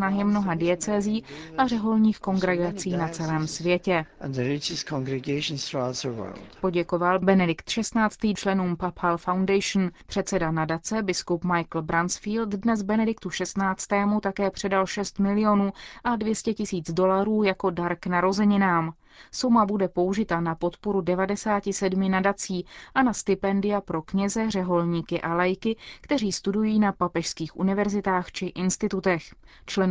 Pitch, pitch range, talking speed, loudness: 190 Hz, 175-205 Hz, 115 wpm, -25 LUFS